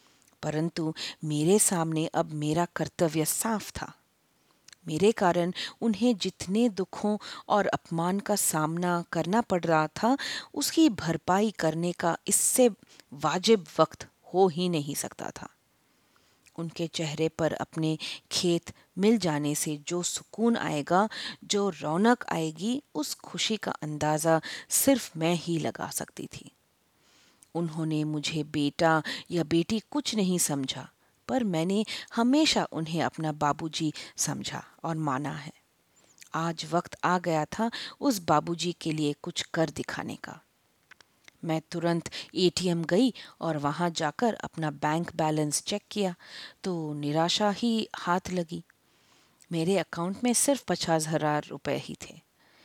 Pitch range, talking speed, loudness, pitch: 155-205 Hz, 130 wpm, -28 LUFS, 170 Hz